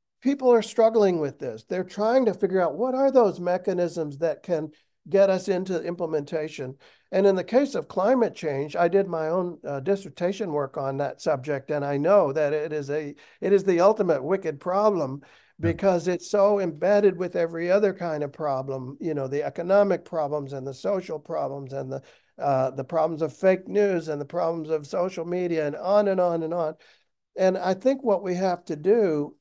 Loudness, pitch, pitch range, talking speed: -25 LUFS, 175 Hz, 150-195 Hz, 200 wpm